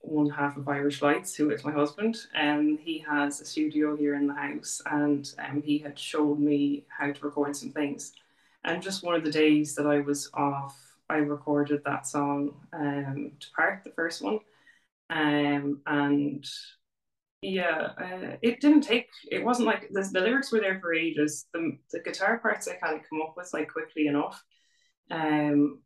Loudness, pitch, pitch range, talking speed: -28 LUFS, 150 Hz, 145-170 Hz, 190 wpm